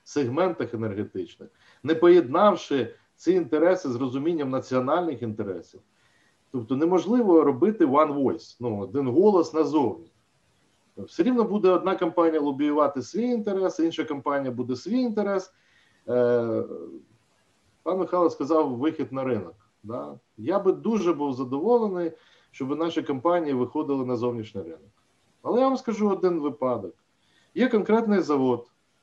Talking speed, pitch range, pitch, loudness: 125 wpm, 130-185 Hz, 155 Hz, -24 LUFS